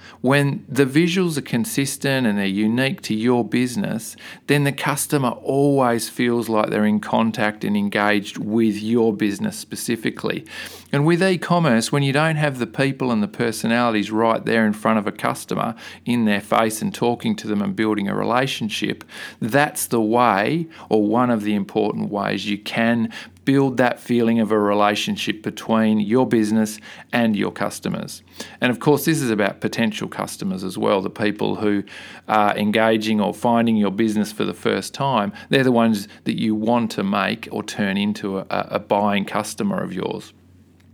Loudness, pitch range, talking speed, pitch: -20 LUFS, 105-130 Hz, 175 wpm, 115 Hz